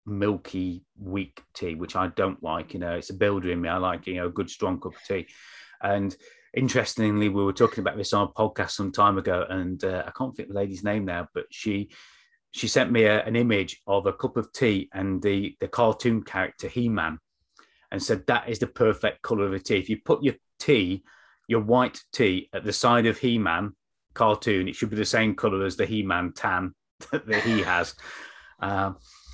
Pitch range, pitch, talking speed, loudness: 95-110 Hz, 100 Hz, 215 wpm, -26 LUFS